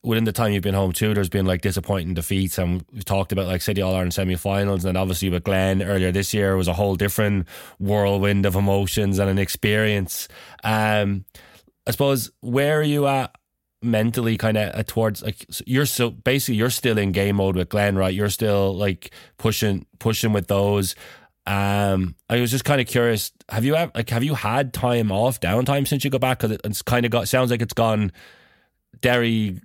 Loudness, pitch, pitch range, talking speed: -22 LUFS, 105 Hz, 95-120 Hz, 205 wpm